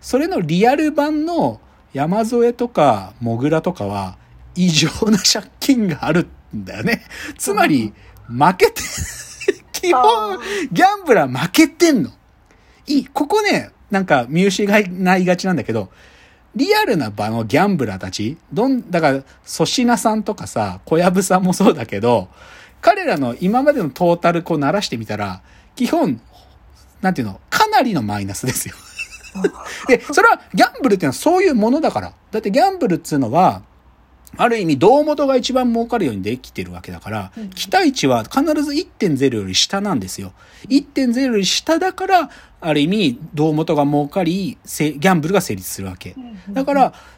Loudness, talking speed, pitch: -17 LUFS, 315 characters per minute, 190 Hz